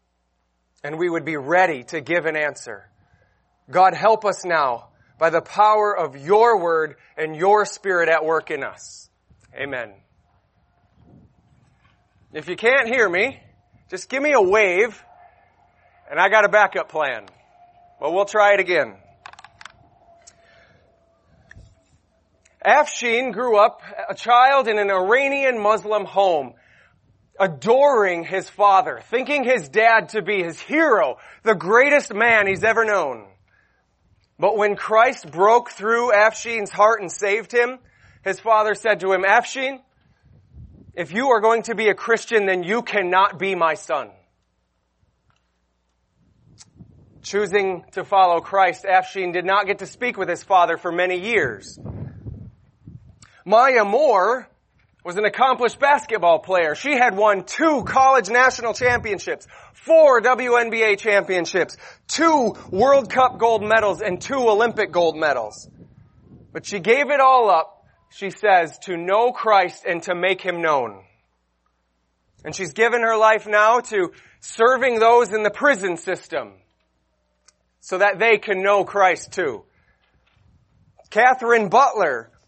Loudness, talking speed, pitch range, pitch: -18 LUFS, 135 wpm, 175-235 Hz, 205 Hz